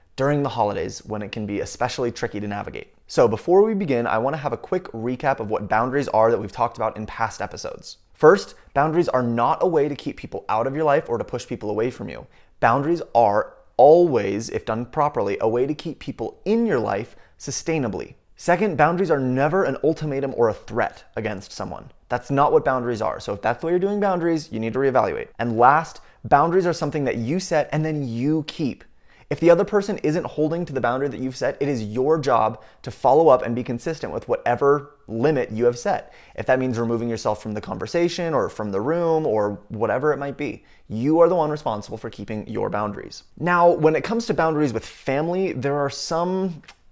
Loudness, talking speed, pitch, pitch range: -22 LUFS, 220 wpm, 140 Hz, 115-165 Hz